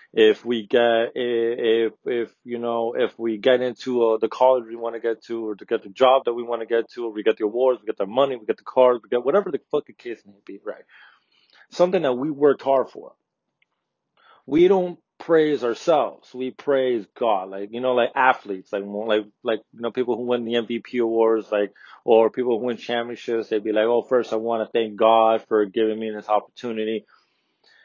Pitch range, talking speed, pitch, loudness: 110-125 Hz, 220 wpm, 115 Hz, -22 LUFS